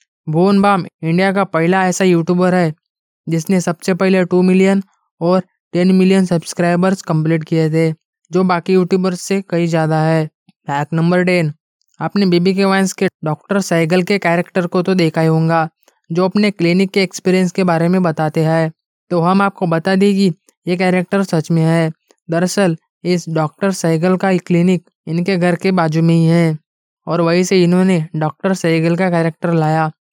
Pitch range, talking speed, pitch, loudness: 165-190 Hz, 175 wpm, 175 Hz, -15 LUFS